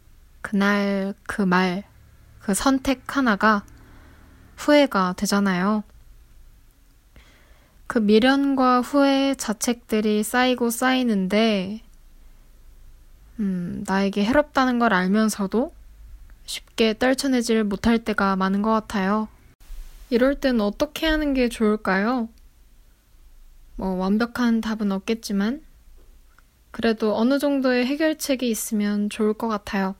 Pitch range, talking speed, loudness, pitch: 200-250 Hz, 215 characters per minute, -22 LUFS, 220 Hz